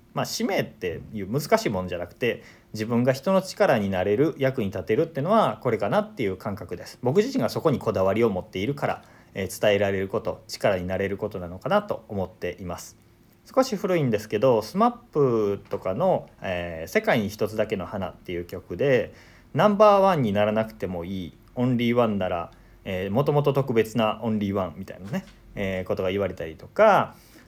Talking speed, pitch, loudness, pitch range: 400 characters per minute, 110 Hz, -25 LUFS, 95-140 Hz